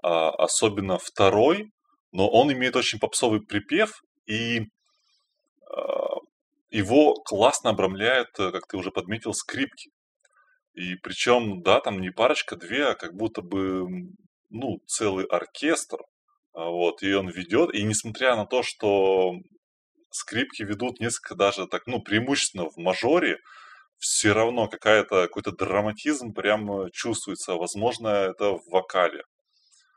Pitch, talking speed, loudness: 115 Hz, 120 wpm, -25 LUFS